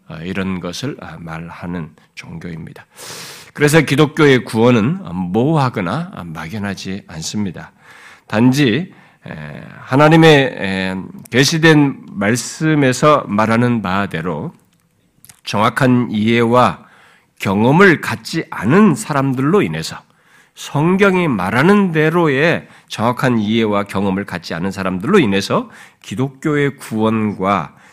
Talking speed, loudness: 235 characters per minute, -15 LUFS